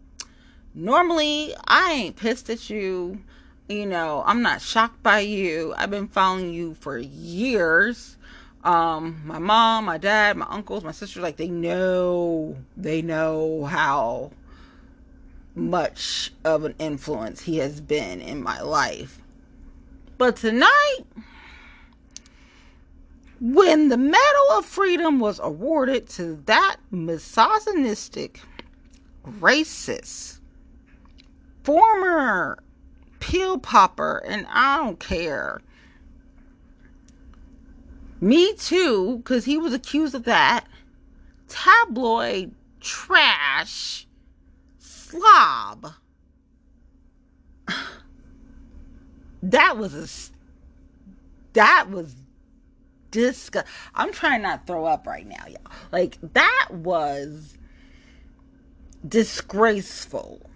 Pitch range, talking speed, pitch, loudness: 155-260 Hz, 95 wpm, 200 Hz, -21 LUFS